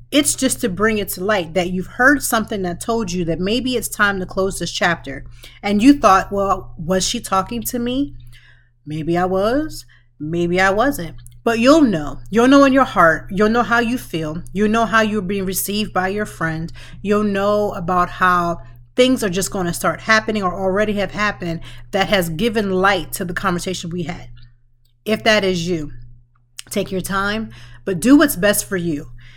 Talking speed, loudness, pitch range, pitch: 195 wpm, -18 LUFS, 165-215 Hz, 190 Hz